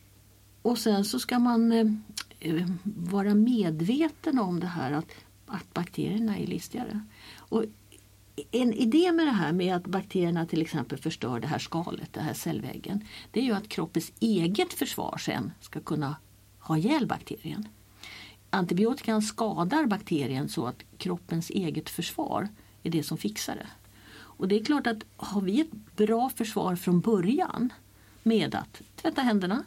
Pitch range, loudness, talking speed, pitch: 155-225 Hz, -29 LUFS, 150 wpm, 185 Hz